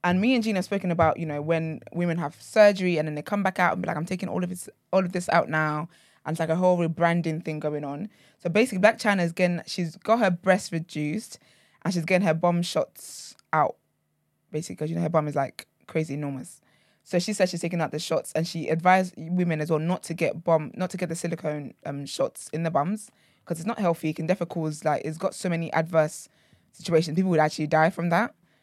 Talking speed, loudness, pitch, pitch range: 245 wpm, -26 LUFS, 170 Hz, 155-185 Hz